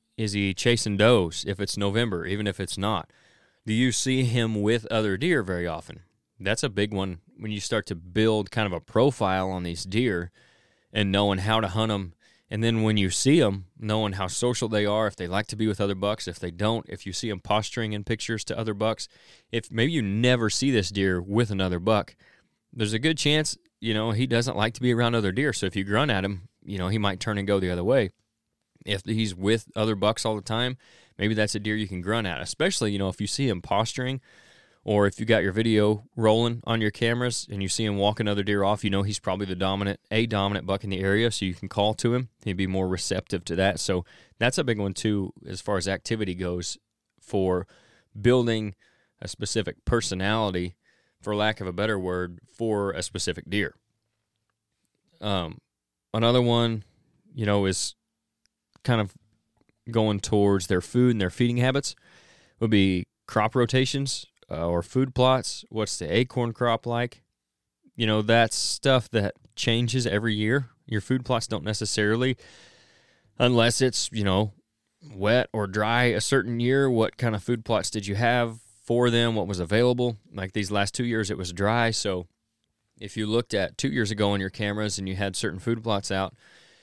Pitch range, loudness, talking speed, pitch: 100-115 Hz, -26 LUFS, 205 wpm, 110 Hz